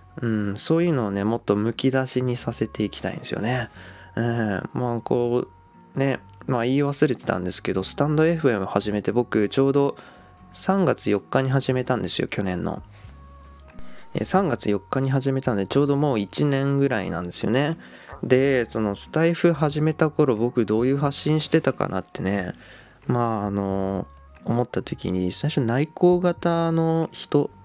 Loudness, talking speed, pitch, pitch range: -23 LUFS, 315 characters per minute, 120 Hz, 100-145 Hz